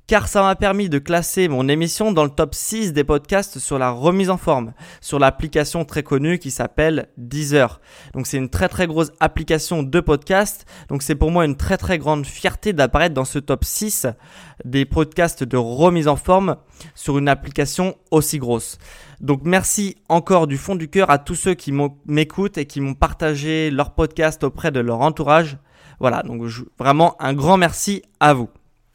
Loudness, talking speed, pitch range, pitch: -19 LUFS, 185 wpm, 140-175 Hz, 155 Hz